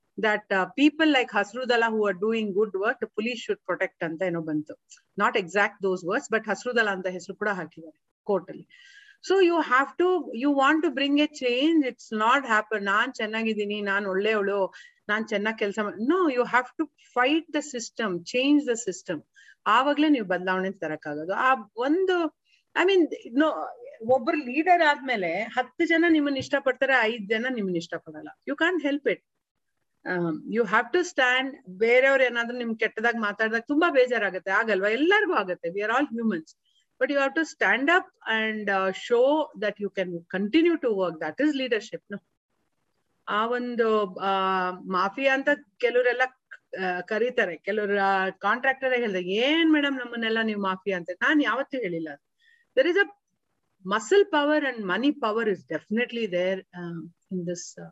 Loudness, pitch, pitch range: -25 LUFS, 230 Hz, 195-280 Hz